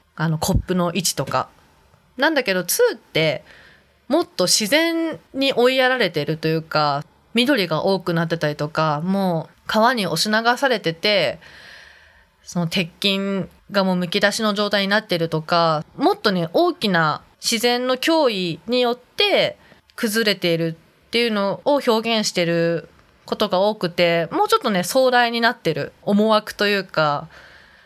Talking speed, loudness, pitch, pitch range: 295 characters per minute, -20 LUFS, 200 Hz, 170-240 Hz